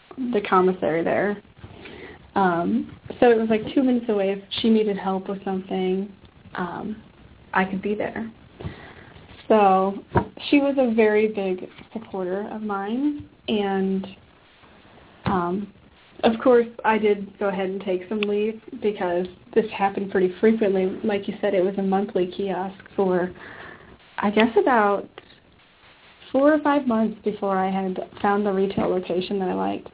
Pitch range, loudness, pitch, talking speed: 190-220 Hz, -23 LUFS, 200 Hz, 150 wpm